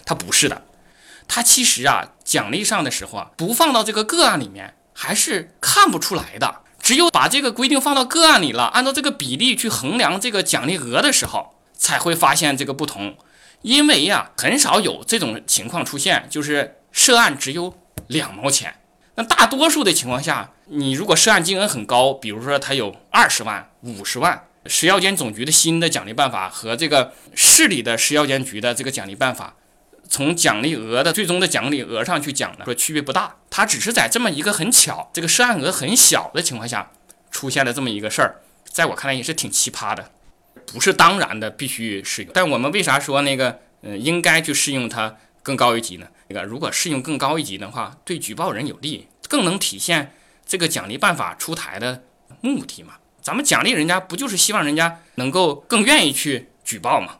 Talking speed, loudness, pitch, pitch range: 305 characters per minute, -17 LUFS, 150 Hz, 130-215 Hz